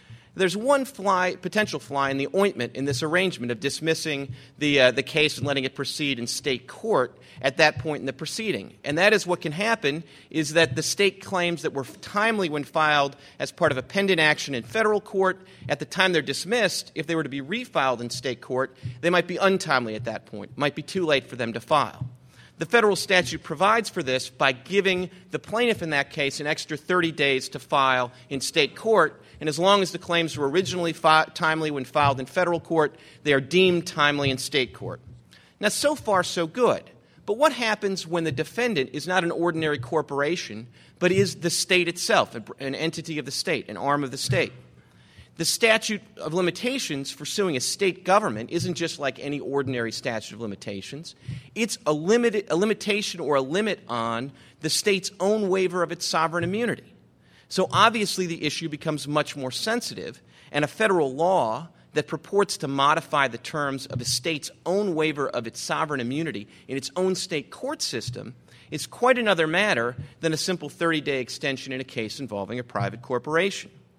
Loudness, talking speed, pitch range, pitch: -24 LUFS, 200 wpm, 135-185 Hz, 155 Hz